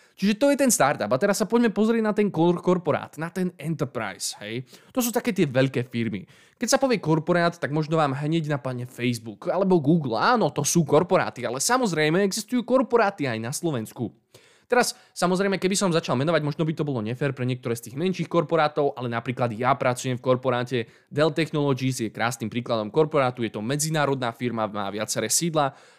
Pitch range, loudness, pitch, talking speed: 125-180 Hz, -24 LUFS, 150 Hz, 190 wpm